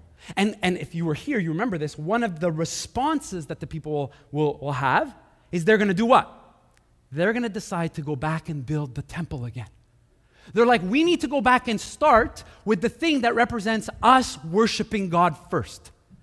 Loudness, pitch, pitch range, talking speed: -23 LUFS, 175 Hz, 150-225 Hz, 205 wpm